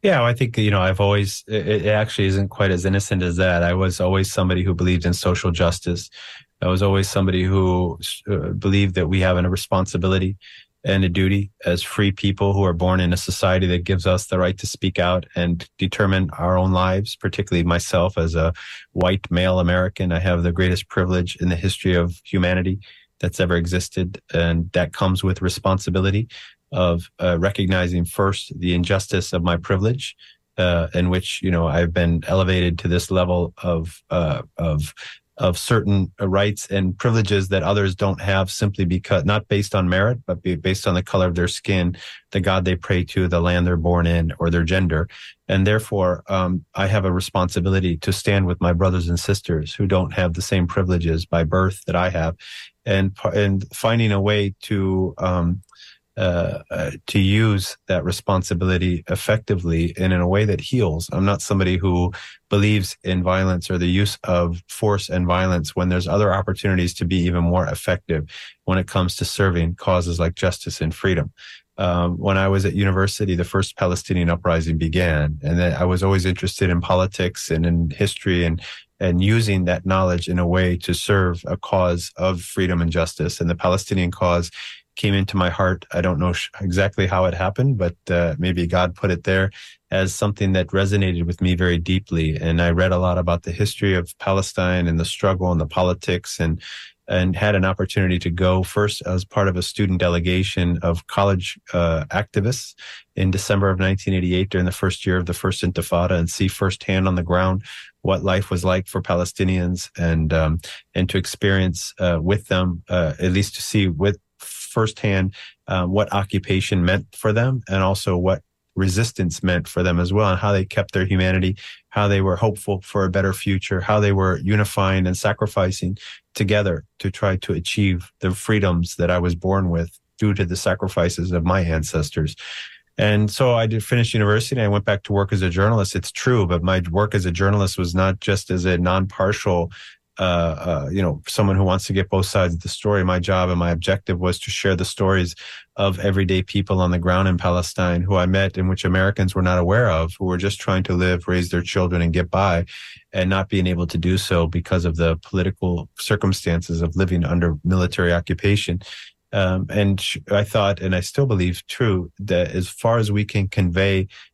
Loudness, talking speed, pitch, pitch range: -20 LUFS, 195 wpm, 95 Hz, 90-100 Hz